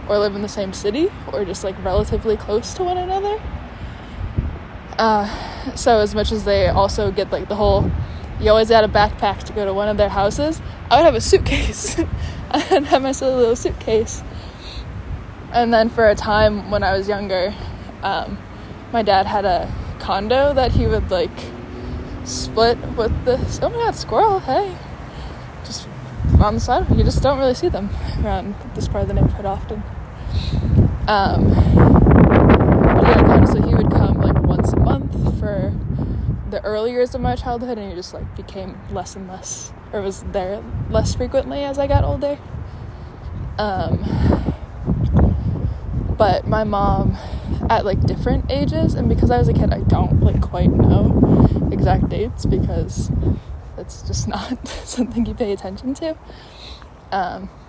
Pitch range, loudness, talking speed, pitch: 205-270 Hz, -18 LUFS, 165 wpm, 225 Hz